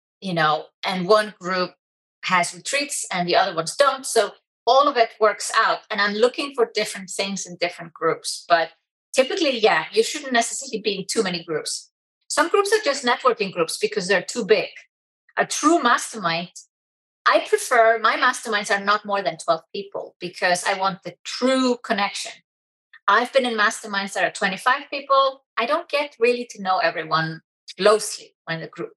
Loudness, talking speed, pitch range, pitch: -21 LUFS, 180 wpm, 185-265 Hz, 215 Hz